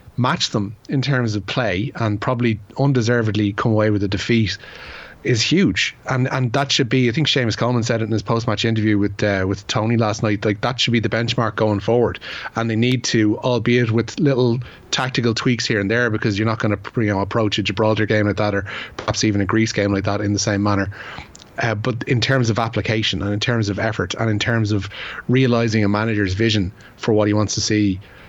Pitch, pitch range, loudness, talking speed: 110 Hz, 105-120 Hz, -19 LUFS, 225 wpm